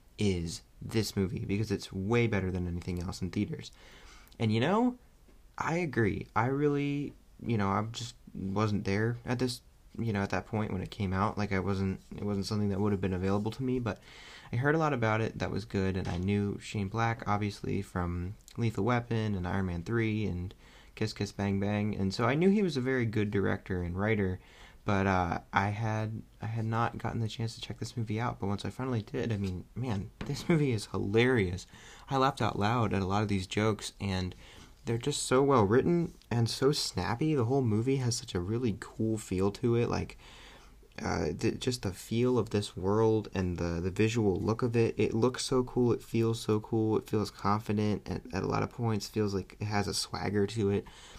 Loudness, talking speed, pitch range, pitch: -32 LUFS, 220 wpm, 100-120 Hz, 105 Hz